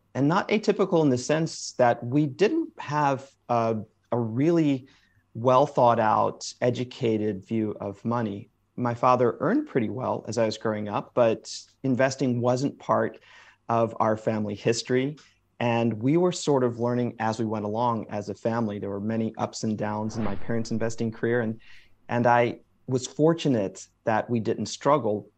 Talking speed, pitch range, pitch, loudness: 170 wpm, 110-130 Hz, 115 Hz, -26 LUFS